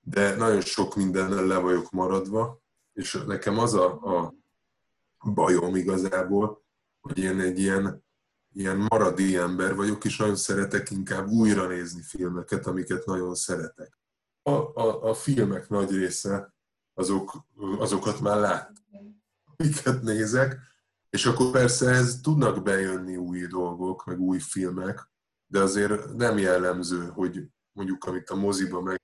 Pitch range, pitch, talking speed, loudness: 95-110 Hz, 95 Hz, 135 wpm, -26 LUFS